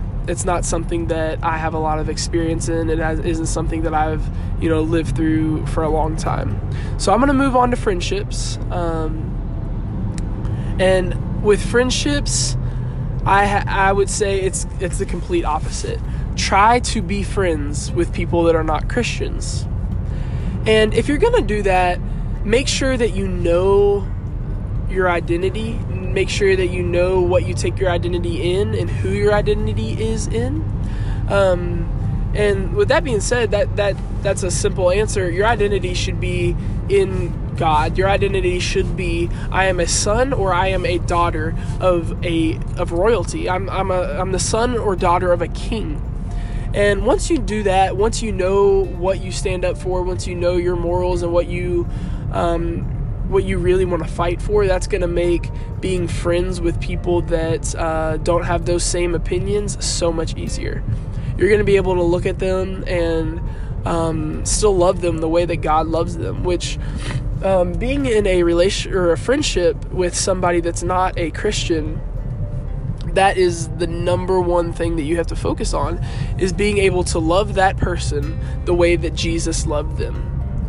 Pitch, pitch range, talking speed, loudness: 160 Hz, 110-180 Hz, 180 wpm, -19 LUFS